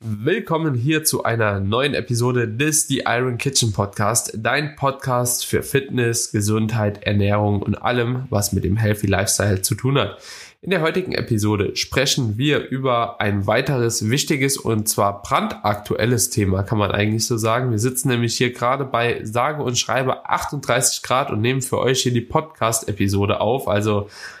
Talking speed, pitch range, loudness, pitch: 160 wpm, 105-130 Hz, -20 LUFS, 115 Hz